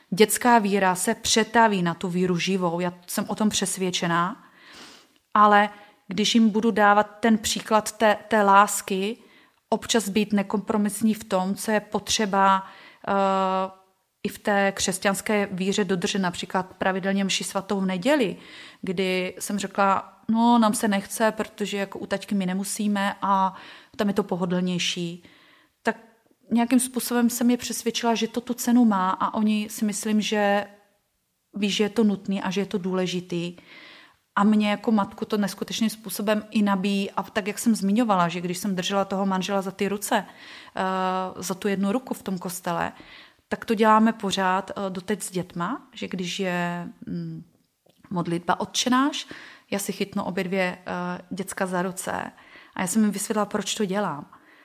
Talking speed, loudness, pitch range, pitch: 160 wpm, -24 LUFS, 190-220 Hz, 205 Hz